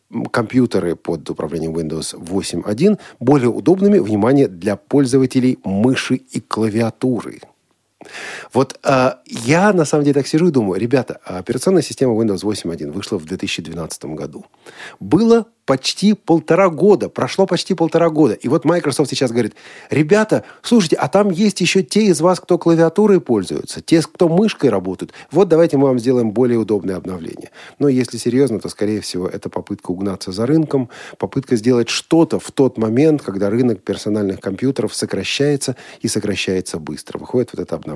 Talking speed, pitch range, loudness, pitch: 155 wpm, 105-165 Hz, -17 LUFS, 130 Hz